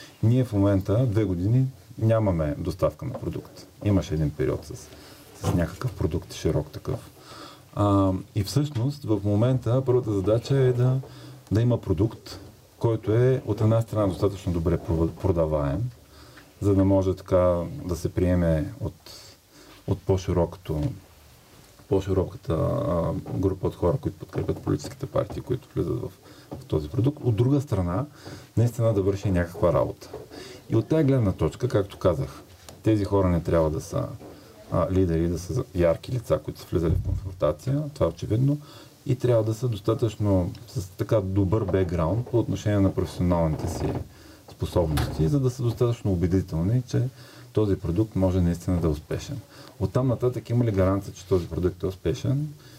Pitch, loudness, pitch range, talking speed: 105 Hz, -25 LUFS, 95-125 Hz, 155 wpm